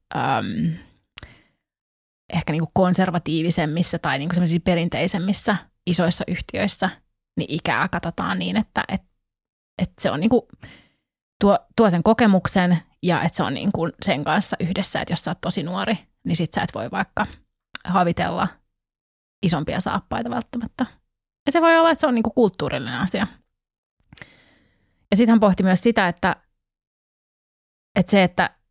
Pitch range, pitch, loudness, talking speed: 170-210 Hz, 185 Hz, -21 LUFS, 140 wpm